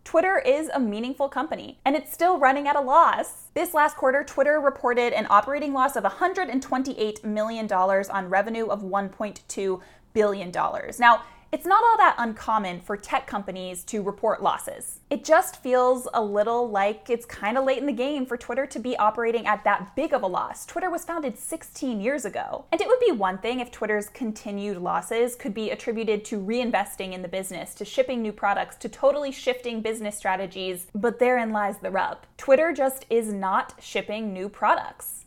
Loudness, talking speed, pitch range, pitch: -25 LUFS, 185 wpm, 205-275 Hz, 235 Hz